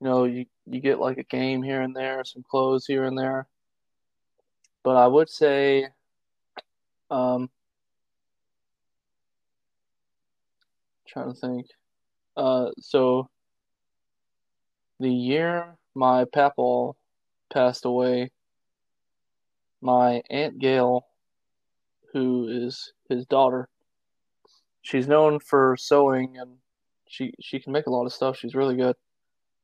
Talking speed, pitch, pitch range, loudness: 115 wpm, 130 Hz, 125-135 Hz, -24 LUFS